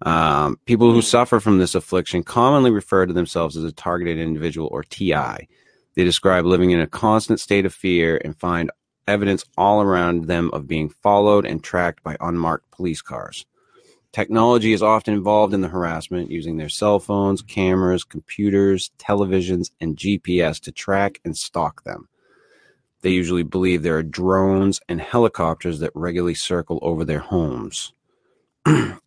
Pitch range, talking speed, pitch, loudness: 85-100 Hz, 155 wpm, 90 Hz, -20 LUFS